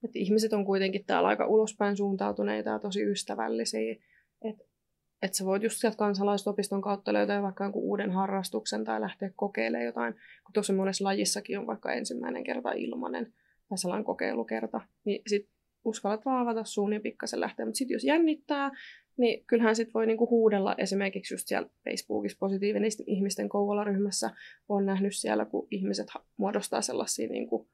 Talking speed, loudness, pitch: 155 wpm, -30 LUFS, 200 Hz